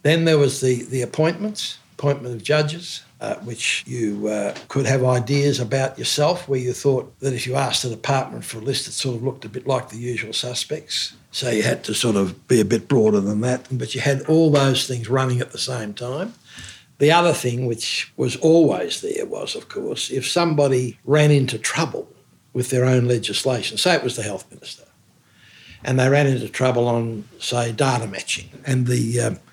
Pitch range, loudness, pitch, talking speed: 120-145 Hz, -21 LUFS, 130 Hz, 205 wpm